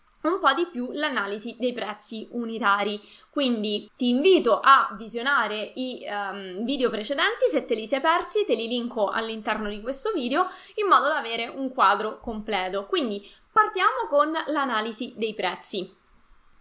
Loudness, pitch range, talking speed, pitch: -25 LUFS, 210-300 Hz, 150 wpm, 245 Hz